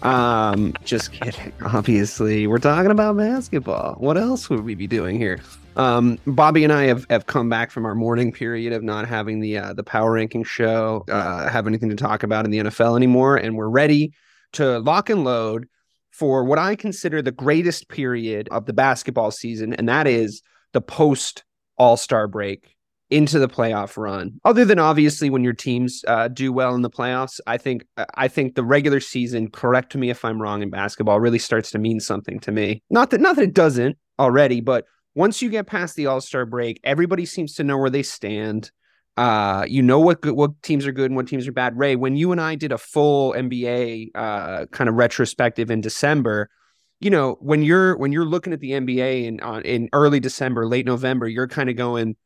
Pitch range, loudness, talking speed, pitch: 110-145 Hz, -20 LUFS, 205 wpm, 125 Hz